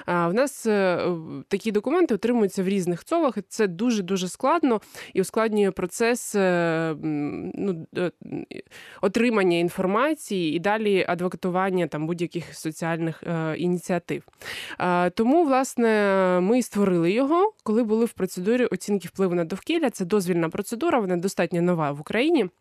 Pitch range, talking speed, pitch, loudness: 175-230 Hz, 120 wpm, 195 Hz, -24 LUFS